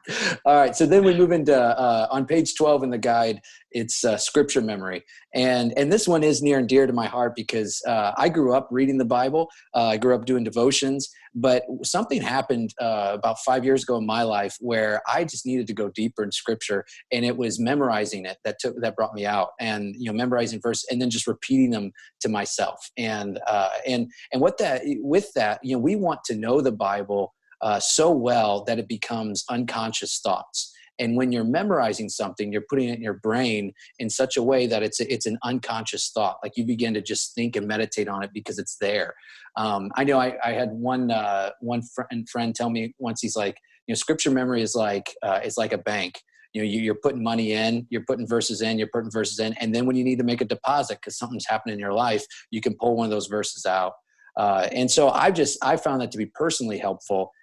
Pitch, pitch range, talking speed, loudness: 115 Hz, 110-130 Hz, 230 wpm, -24 LUFS